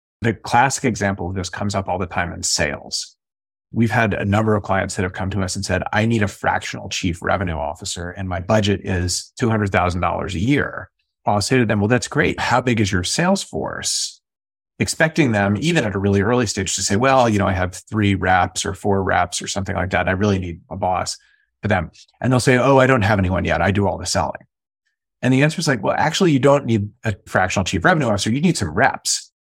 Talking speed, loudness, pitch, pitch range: 235 wpm, -19 LUFS, 100 Hz, 95-120 Hz